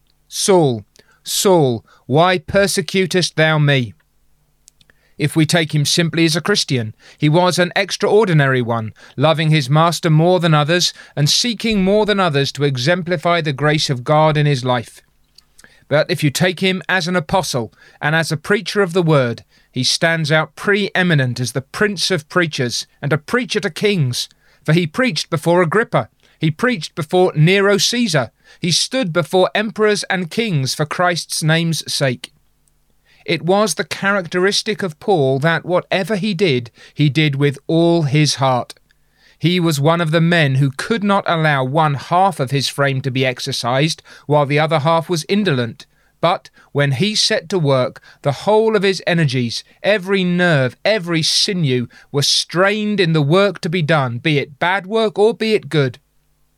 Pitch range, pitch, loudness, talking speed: 145-190 Hz, 165 Hz, -16 LUFS, 170 wpm